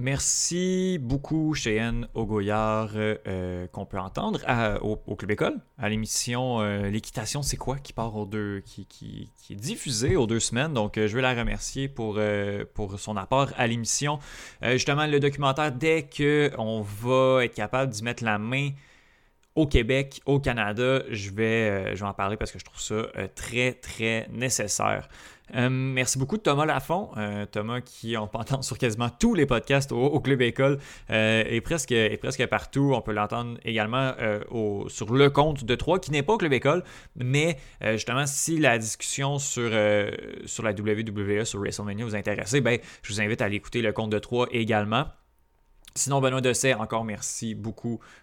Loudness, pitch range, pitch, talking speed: -26 LUFS, 105-135 Hz, 115 Hz, 190 wpm